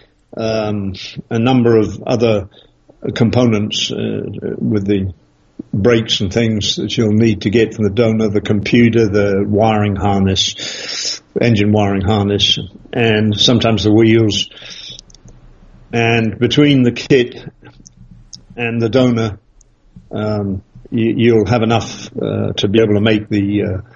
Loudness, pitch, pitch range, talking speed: -14 LUFS, 110 Hz, 105-115 Hz, 130 wpm